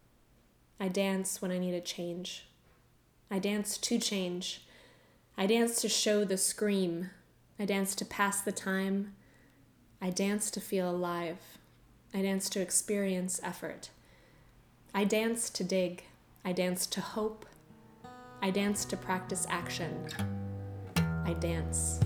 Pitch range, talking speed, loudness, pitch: 155-200 Hz, 130 wpm, -33 LUFS, 190 Hz